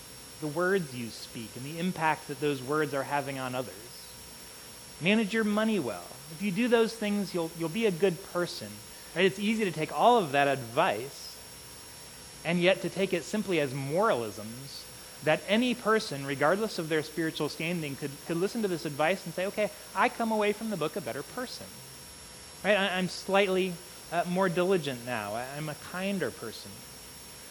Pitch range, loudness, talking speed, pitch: 140-200 Hz, -30 LUFS, 185 wpm, 170 Hz